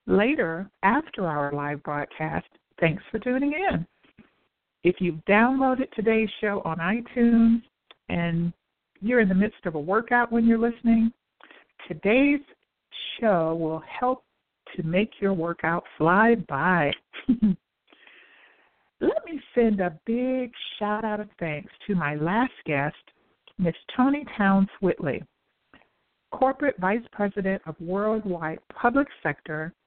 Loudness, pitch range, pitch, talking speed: -25 LUFS, 170-240 Hz, 205 Hz, 125 wpm